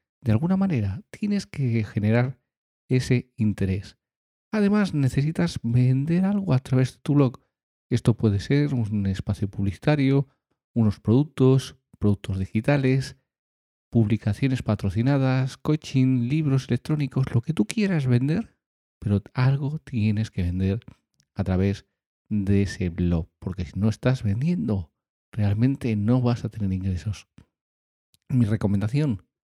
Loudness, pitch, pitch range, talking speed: -24 LUFS, 120 Hz, 100-135 Hz, 120 wpm